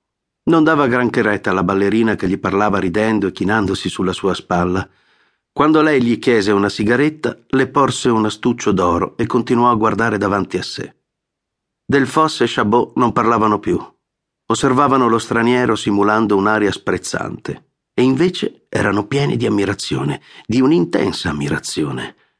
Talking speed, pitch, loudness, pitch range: 145 wpm, 110 Hz, -16 LUFS, 100-125 Hz